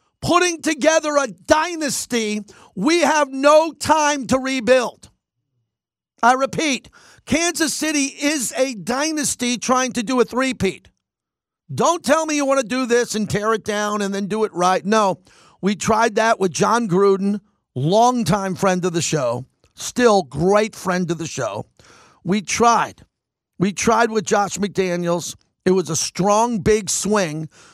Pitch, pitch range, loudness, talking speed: 220 Hz, 190-265 Hz, -19 LUFS, 150 wpm